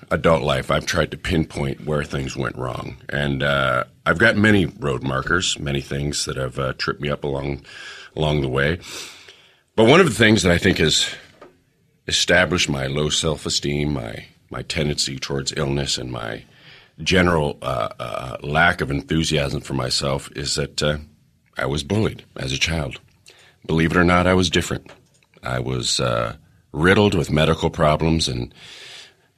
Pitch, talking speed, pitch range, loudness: 75 Hz, 165 wpm, 70-85 Hz, -20 LUFS